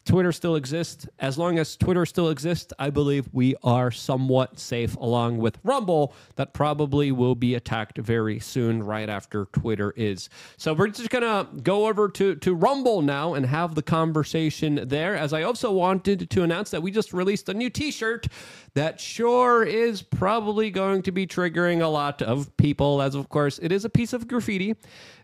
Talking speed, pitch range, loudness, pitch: 190 wpm, 135-195 Hz, -24 LUFS, 155 Hz